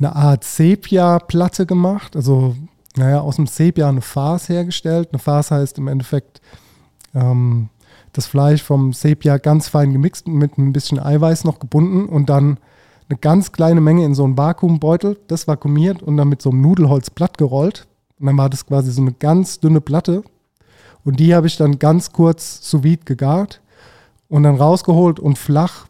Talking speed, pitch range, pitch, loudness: 175 wpm, 140-165 Hz, 150 Hz, -15 LUFS